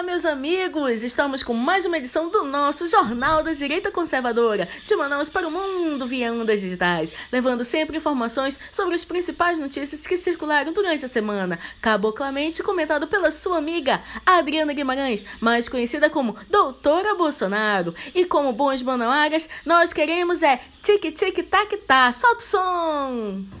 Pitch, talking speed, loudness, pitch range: 300 Hz, 155 wpm, -21 LUFS, 255-350 Hz